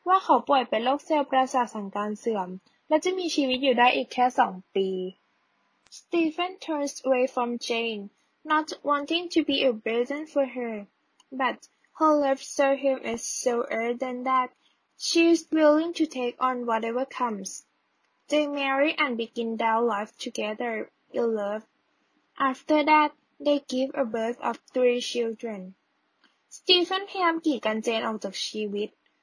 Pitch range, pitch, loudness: 230-300 Hz, 255 Hz, -26 LUFS